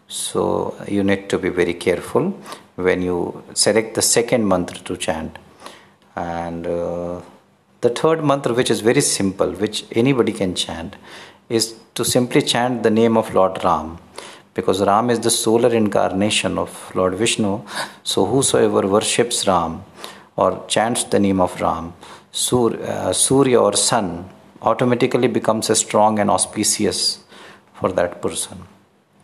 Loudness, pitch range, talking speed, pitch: -18 LUFS, 95-120 Hz, 145 wpm, 105 Hz